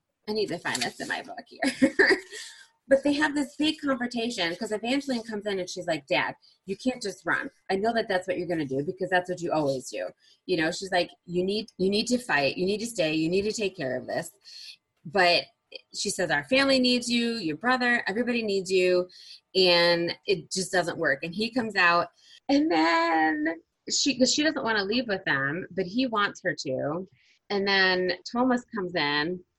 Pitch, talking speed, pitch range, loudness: 195 Hz, 210 wpm, 175-245 Hz, -26 LUFS